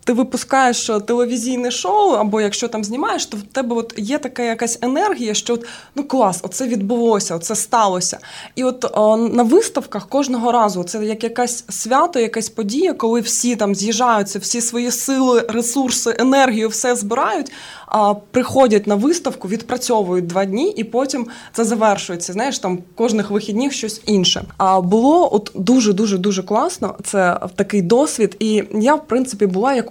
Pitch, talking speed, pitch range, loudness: 230 Hz, 165 wpm, 210-250 Hz, -17 LUFS